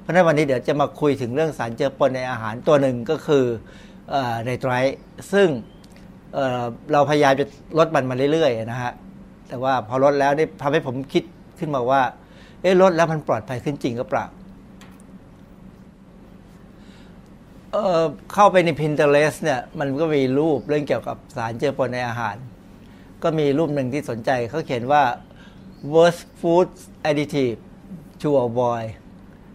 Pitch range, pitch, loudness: 125-160 Hz, 145 Hz, -21 LUFS